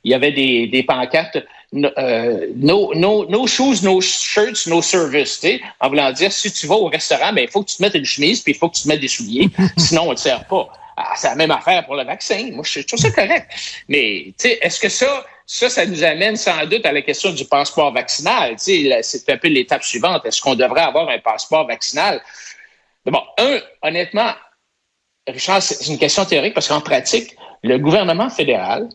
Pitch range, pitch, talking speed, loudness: 155-225 Hz, 195 Hz, 215 wpm, -16 LUFS